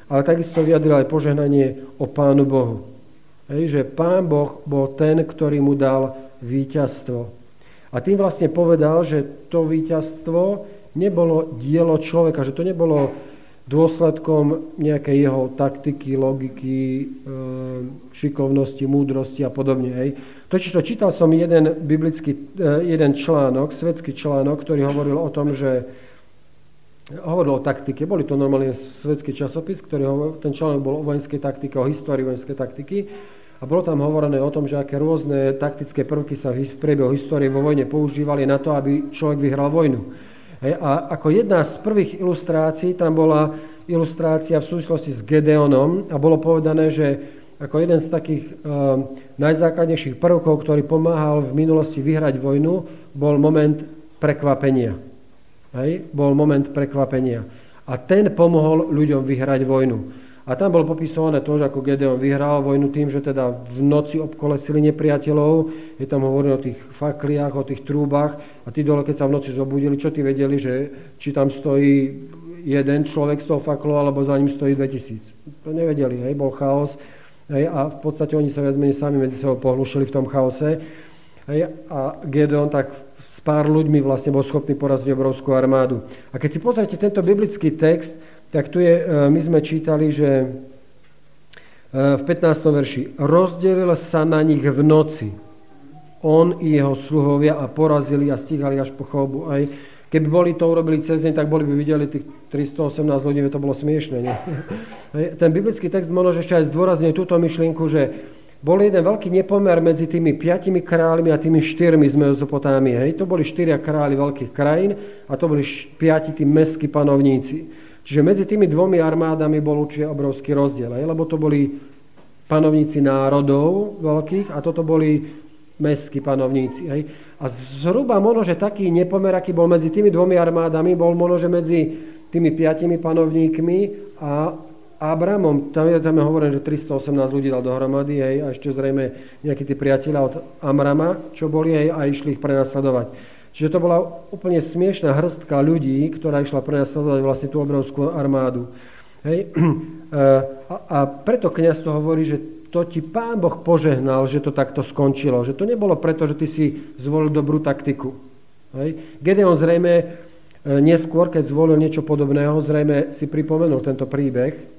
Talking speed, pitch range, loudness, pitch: 160 wpm, 140-160 Hz, -19 LUFS, 150 Hz